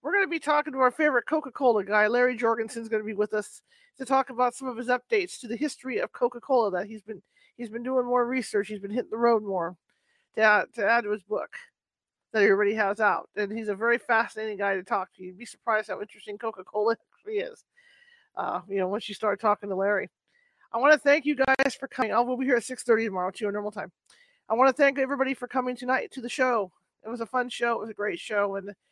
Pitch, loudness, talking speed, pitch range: 235 Hz, -26 LUFS, 255 wpm, 210-265 Hz